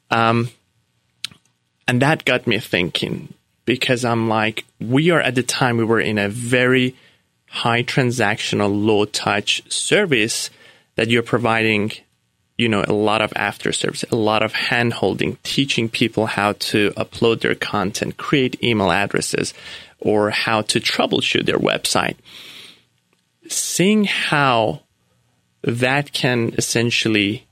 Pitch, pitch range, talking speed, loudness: 115 Hz, 105-125 Hz, 130 wpm, -18 LUFS